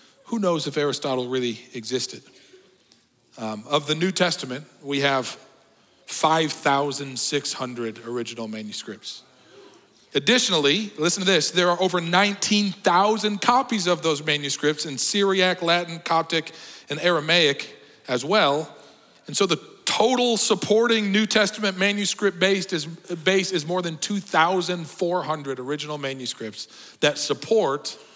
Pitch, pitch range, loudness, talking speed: 165 Hz, 140-190 Hz, -22 LUFS, 115 wpm